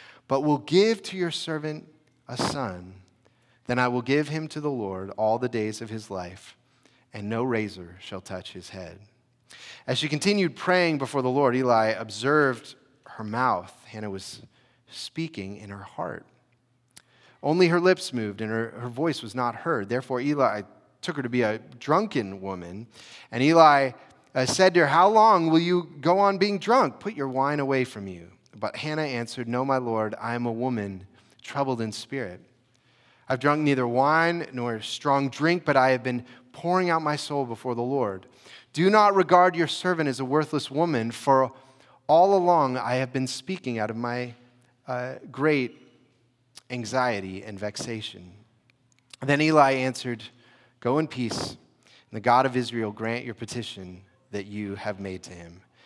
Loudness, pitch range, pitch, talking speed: -25 LUFS, 115-145 Hz, 125 Hz, 175 wpm